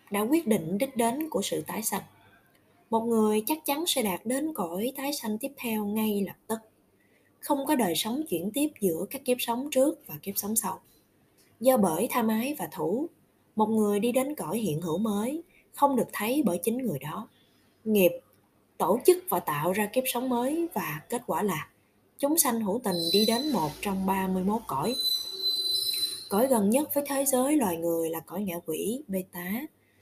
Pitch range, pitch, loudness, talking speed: 195-270 Hz, 225 Hz, -28 LUFS, 195 wpm